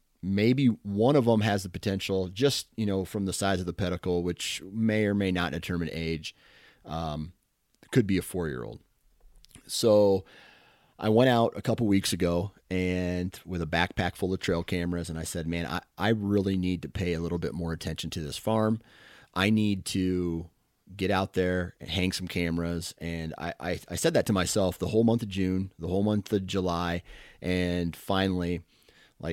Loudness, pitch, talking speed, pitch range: -28 LUFS, 90 Hz, 190 wpm, 85-100 Hz